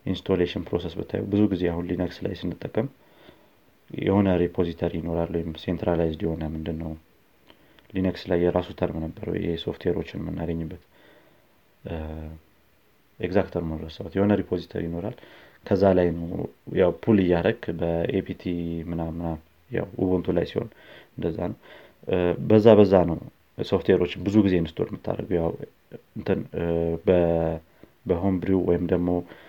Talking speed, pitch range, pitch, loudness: 110 wpm, 80-95 Hz, 85 Hz, -25 LUFS